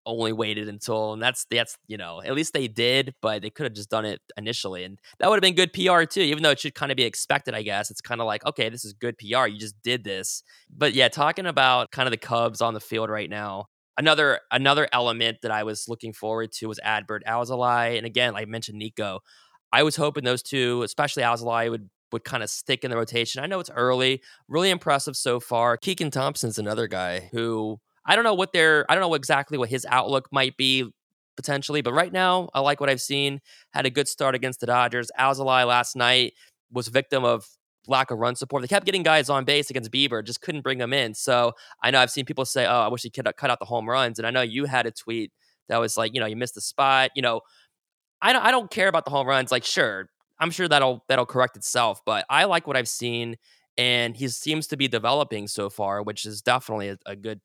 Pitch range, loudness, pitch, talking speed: 115-140 Hz, -23 LUFS, 125 Hz, 245 wpm